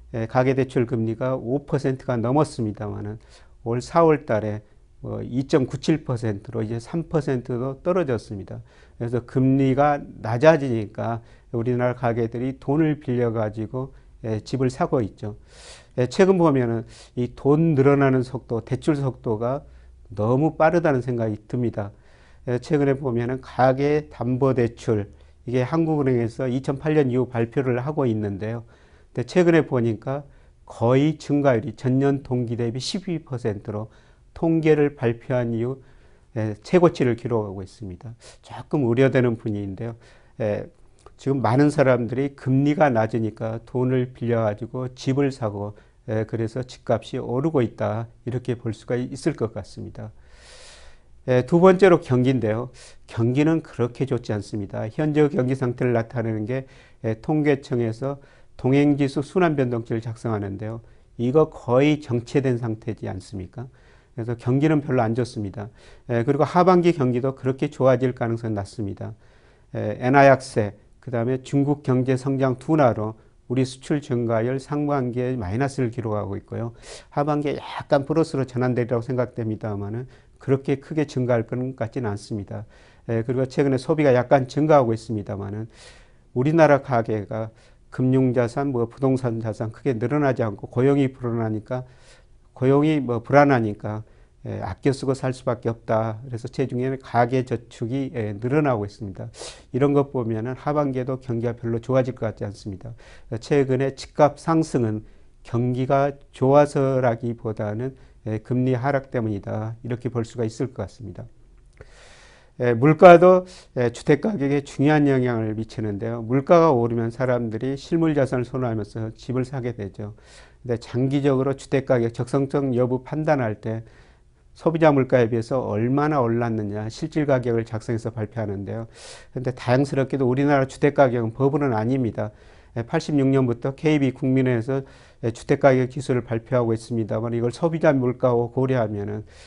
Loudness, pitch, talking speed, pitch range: -22 LUFS, 125 Hz, 315 characters per minute, 115-135 Hz